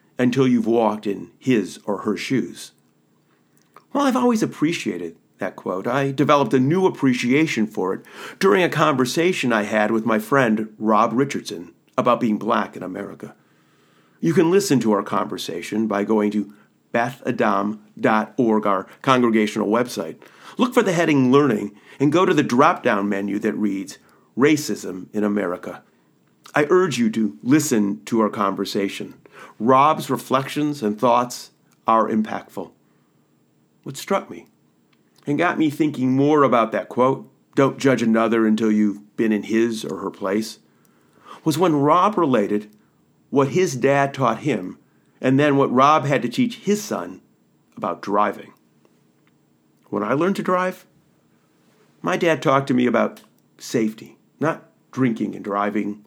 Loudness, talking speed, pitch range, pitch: -20 LUFS, 150 wpm, 105-145 Hz, 115 Hz